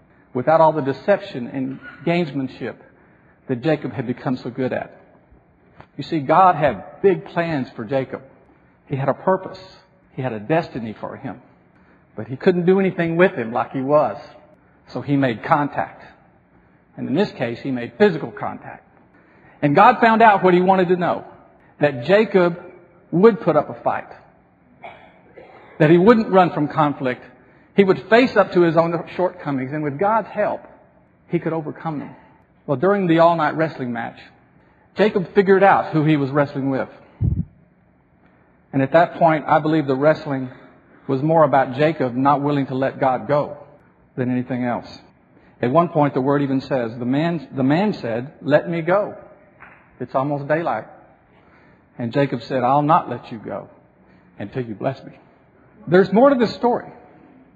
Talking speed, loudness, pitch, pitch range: 170 wpm, -19 LUFS, 150 Hz, 130-180 Hz